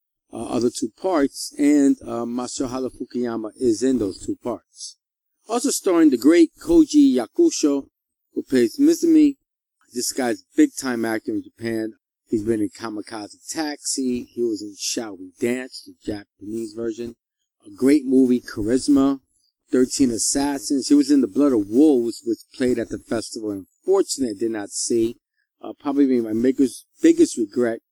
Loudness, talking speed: -21 LUFS, 155 wpm